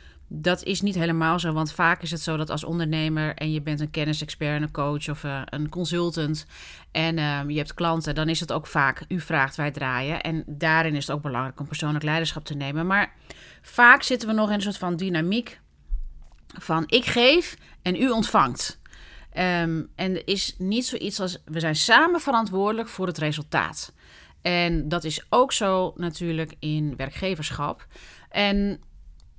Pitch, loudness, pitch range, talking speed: 160 Hz, -24 LUFS, 150-185 Hz, 180 wpm